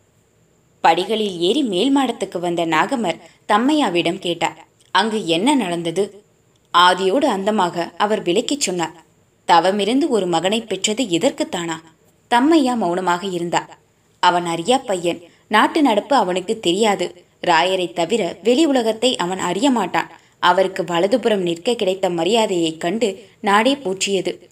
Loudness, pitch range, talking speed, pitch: -18 LUFS, 175-230 Hz, 115 wpm, 190 Hz